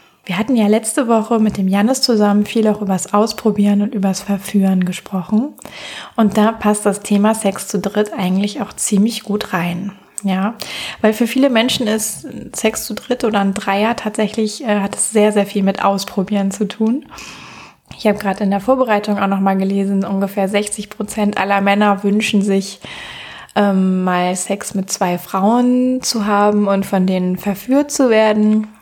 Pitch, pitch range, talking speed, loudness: 205 Hz, 195-220 Hz, 175 wpm, -16 LUFS